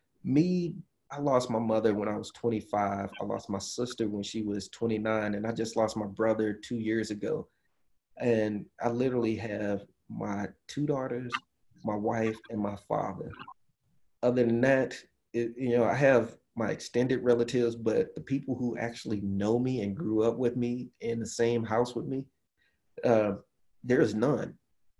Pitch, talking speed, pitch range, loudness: 115 Hz, 170 wpm, 105-125 Hz, -30 LUFS